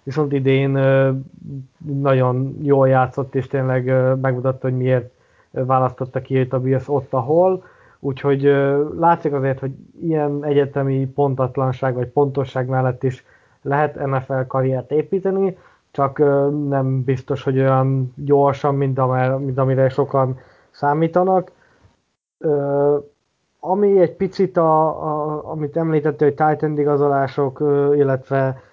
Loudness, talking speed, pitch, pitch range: -19 LUFS, 110 wpm, 140 Hz, 130-150 Hz